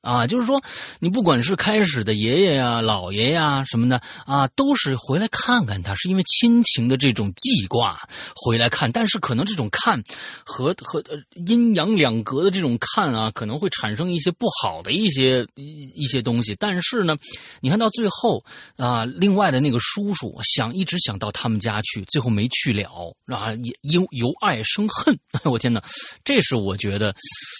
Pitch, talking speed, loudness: 135 Hz, 265 characters per minute, -20 LUFS